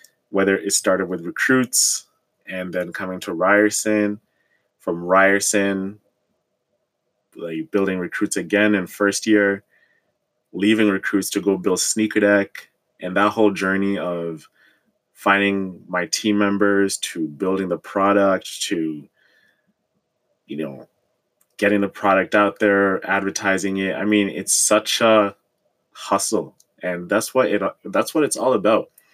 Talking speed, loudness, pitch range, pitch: 130 wpm, -19 LUFS, 95-105 Hz, 100 Hz